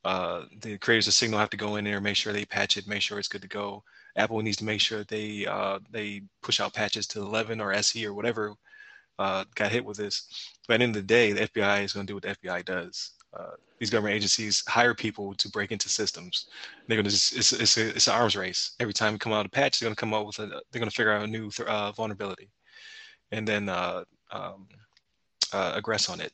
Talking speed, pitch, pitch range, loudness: 240 wpm, 105 Hz, 105-110 Hz, -27 LUFS